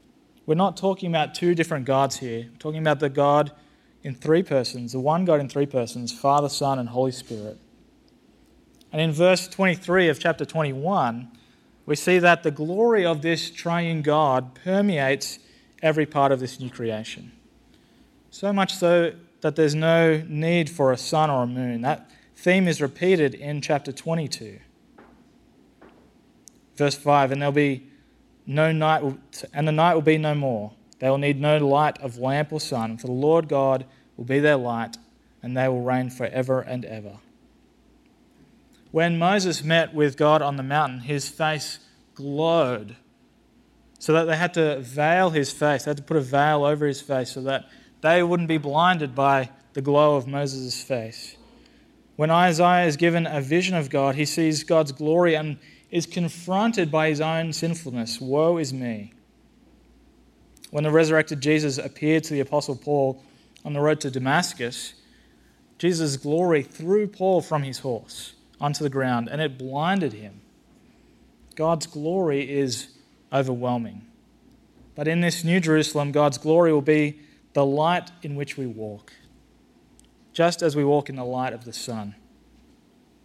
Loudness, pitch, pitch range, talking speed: -23 LUFS, 150 Hz, 135-165 Hz, 165 wpm